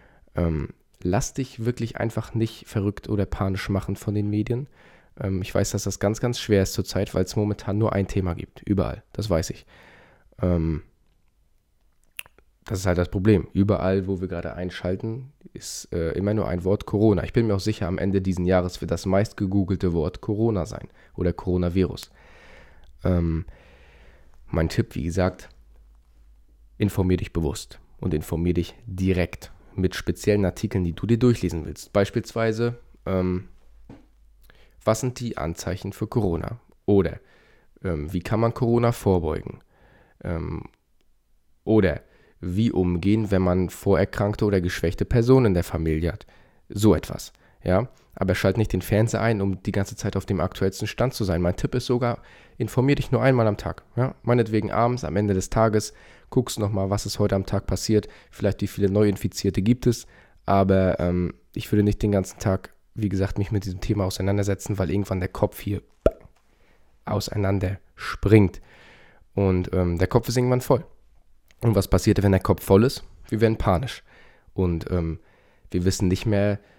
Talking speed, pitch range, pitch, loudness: 170 wpm, 90-110 Hz, 100 Hz, -24 LUFS